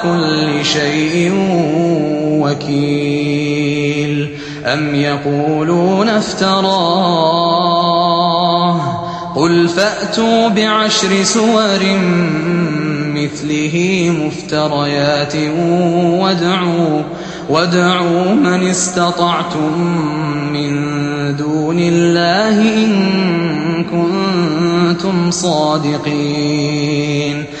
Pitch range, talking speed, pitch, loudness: 150-175 Hz, 50 wpm, 170 Hz, -14 LUFS